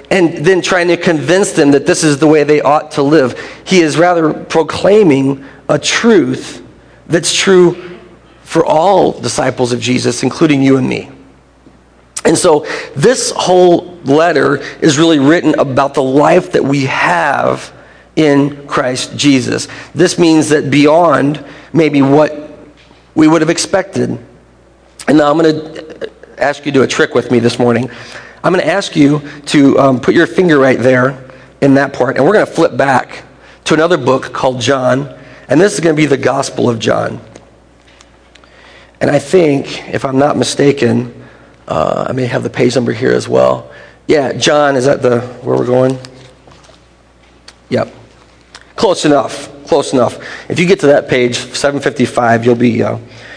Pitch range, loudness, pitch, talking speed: 125-155 Hz, -11 LUFS, 140 Hz, 170 wpm